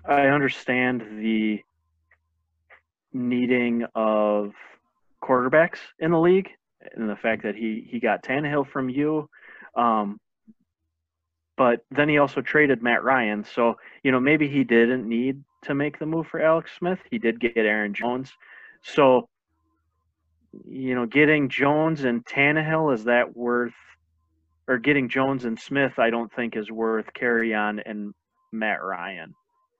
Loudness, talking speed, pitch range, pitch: -23 LUFS, 145 wpm, 105-145 Hz, 120 Hz